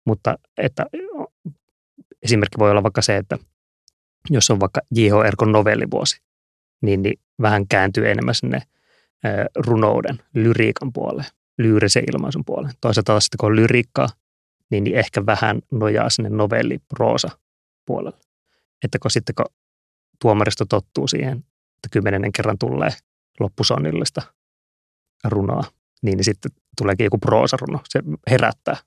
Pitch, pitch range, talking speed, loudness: 105 Hz, 95-115 Hz, 125 wpm, -19 LUFS